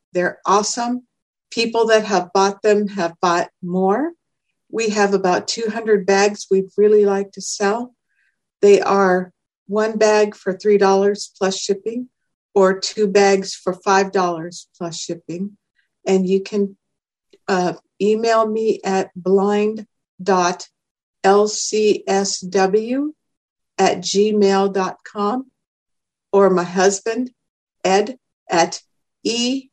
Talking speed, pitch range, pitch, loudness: 105 wpm, 190-220 Hz, 200 Hz, -18 LUFS